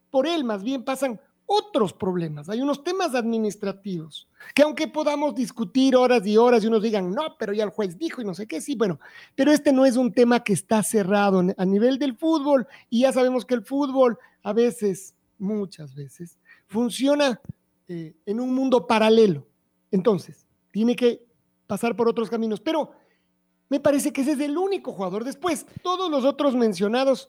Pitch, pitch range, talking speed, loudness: 235 Hz, 205-275 Hz, 180 wpm, -23 LUFS